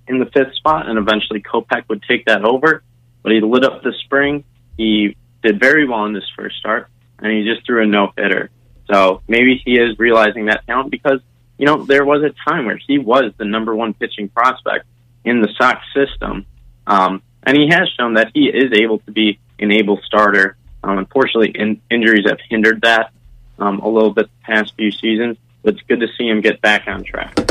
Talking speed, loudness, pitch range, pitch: 210 wpm, -15 LUFS, 105-125 Hz, 115 Hz